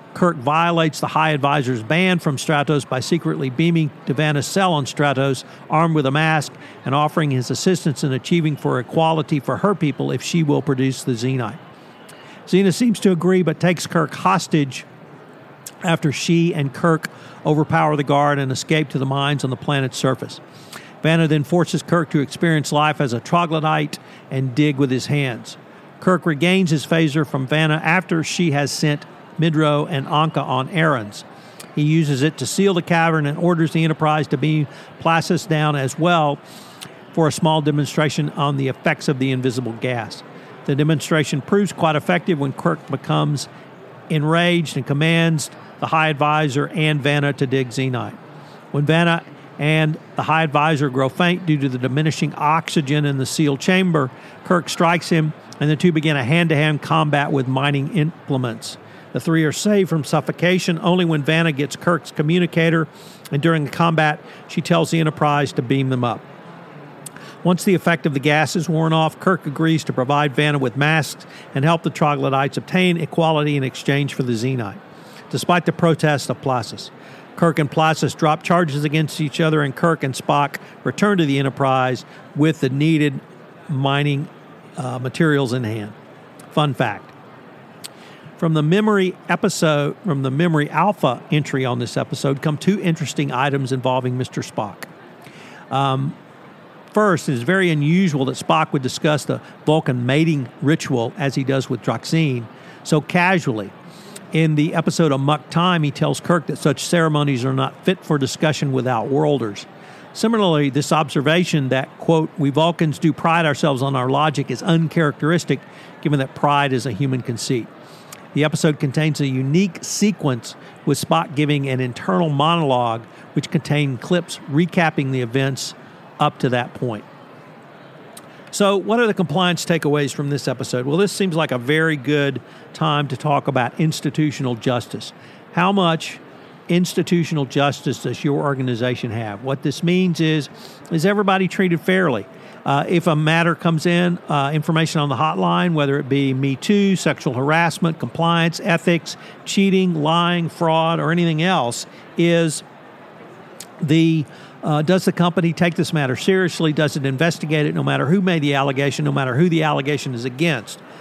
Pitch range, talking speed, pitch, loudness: 140-170 Hz, 165 wpm, 155 Hz, -19 LUFS